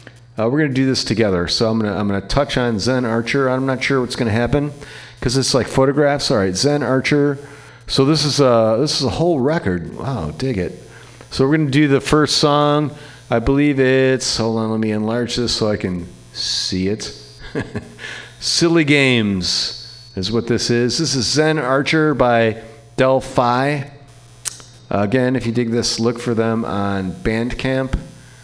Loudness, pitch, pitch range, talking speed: -17 LUFS, 125 Hz, 115-140 Hz, 180 wpm